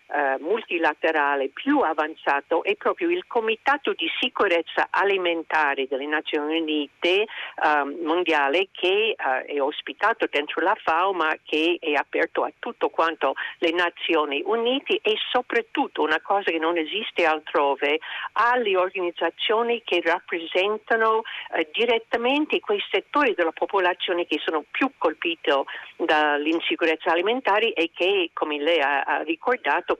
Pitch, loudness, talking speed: 185 Hz, -23 LUFS, 125 wpm